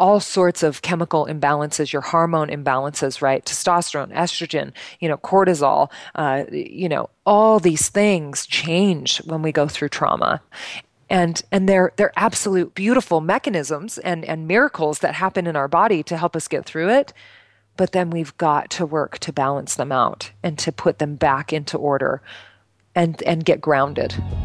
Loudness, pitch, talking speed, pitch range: -20 LUFS, 165 Hz, 165 wpm, 150-185 Hz